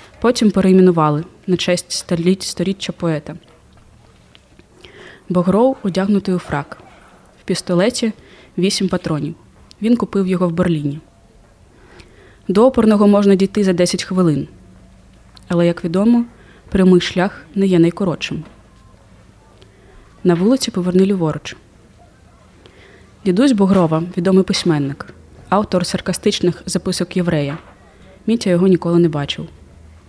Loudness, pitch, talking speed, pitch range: -16 LUFS, 180 Hz, 100 wpm, 150-195 Hz